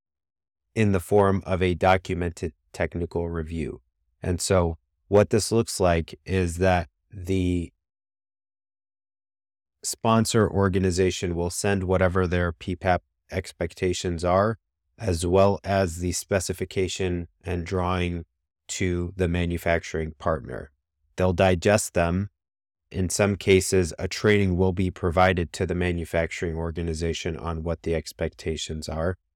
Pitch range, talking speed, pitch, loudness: 85-95 Hz, 115 wpm, 90 Hz, -25 LUFS